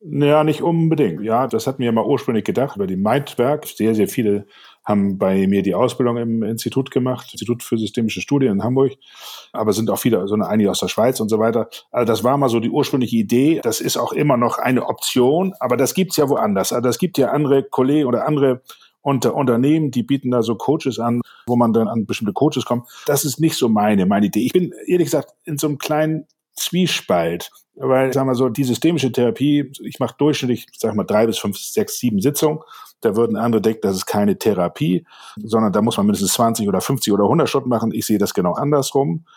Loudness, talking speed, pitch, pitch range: -18 LUFS, 220 wpm, 130 Hz, 115-145 Hz